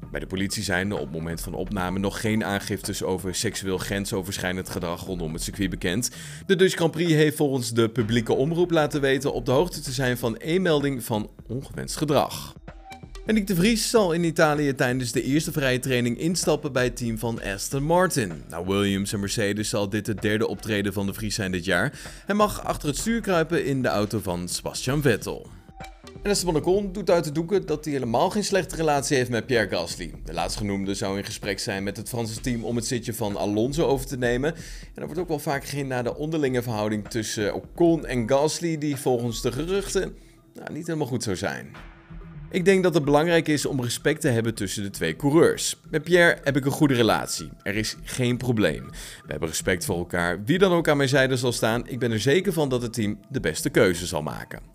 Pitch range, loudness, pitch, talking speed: 105-155 Hz, -24 LUFS, 125 Hz, 220 wpm